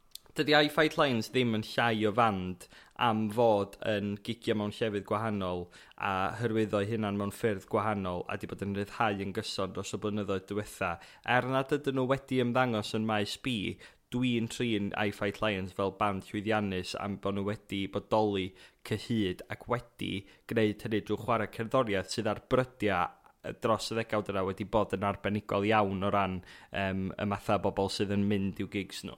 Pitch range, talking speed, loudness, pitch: 100-115 Hz, 180 wpm, -32 LUFS, 105 Hz